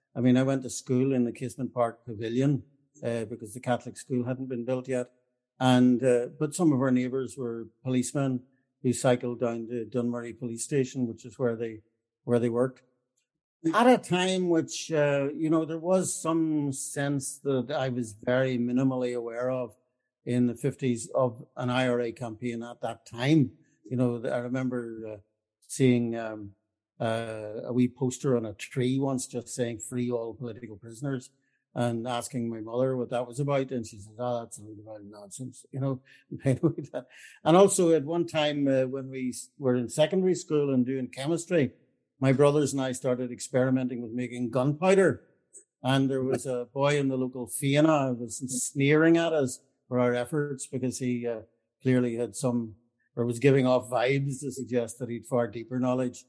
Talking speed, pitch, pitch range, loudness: 180 wpm, 125 Hz, 120-135 Hz, -28 LUFS